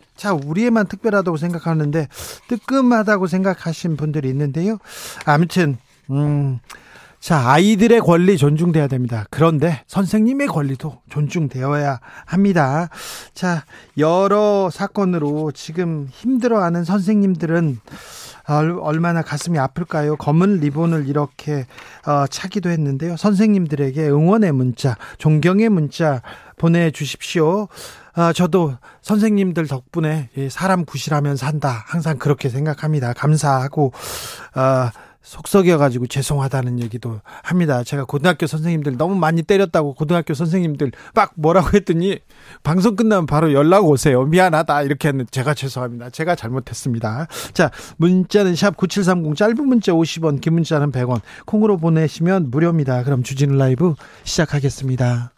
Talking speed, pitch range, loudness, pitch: 320 characters per minute, 140-180 Hz, -18 LUFS, 155 Hz